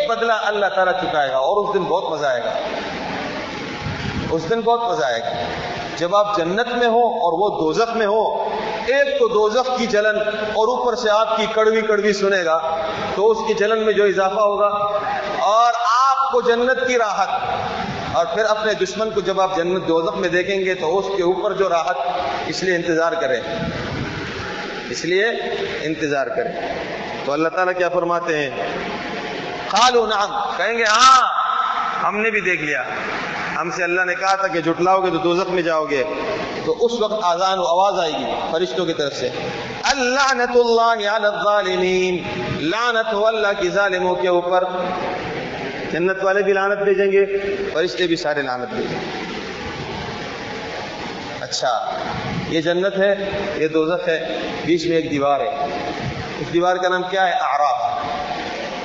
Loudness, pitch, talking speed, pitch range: -19 LUFS, 195 Hz, 165 wpm, 175-220 Hz